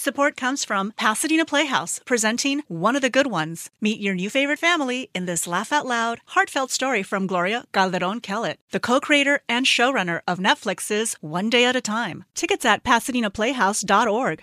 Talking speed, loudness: 175 wpm, -21 LUFS